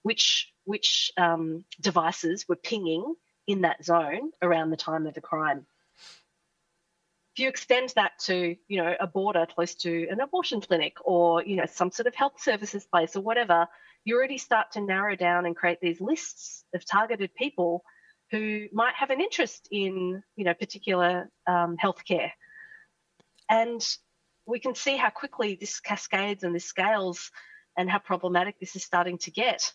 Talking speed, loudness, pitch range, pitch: 165 wpm, -27 LUFS, 170-205 Hz, 175 Hz